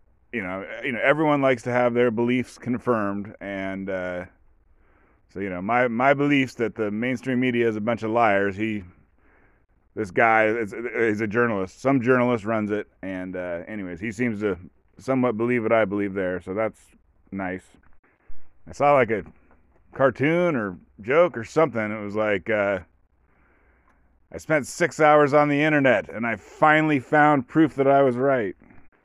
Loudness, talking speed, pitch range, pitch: -23 LUFS, 175 wpm, 95-130 Hz, 110 Hz